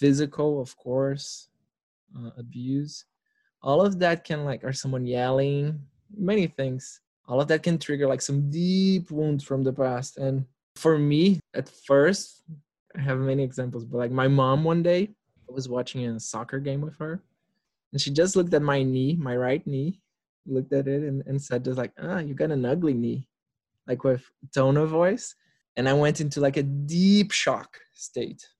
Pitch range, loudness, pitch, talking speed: 130-160 Hz, -25 LUFS, 140 Hz, 185 wpm